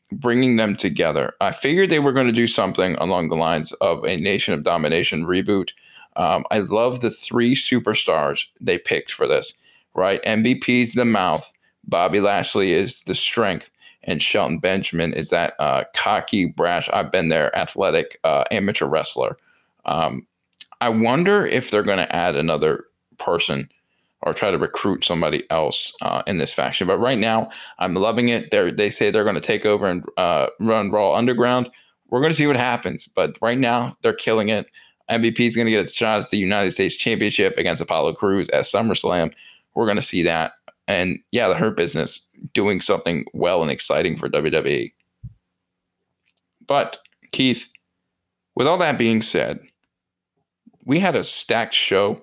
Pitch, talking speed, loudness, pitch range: 115 Hz, 175 wpm, -20 LUFS, 100-125 Hz